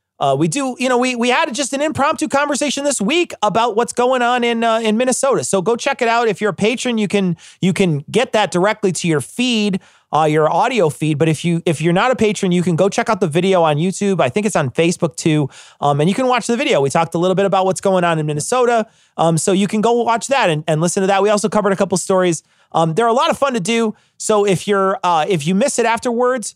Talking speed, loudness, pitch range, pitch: 275 wpm, -16 LUFS, 175-235 Hz, 205 Hz